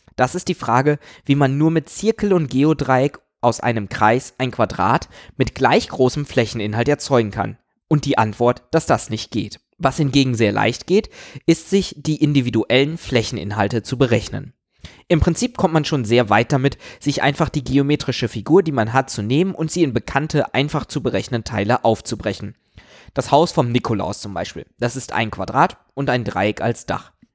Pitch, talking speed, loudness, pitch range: 130 Hz, 180 wpm, -19 LUFS, 115-150 Hz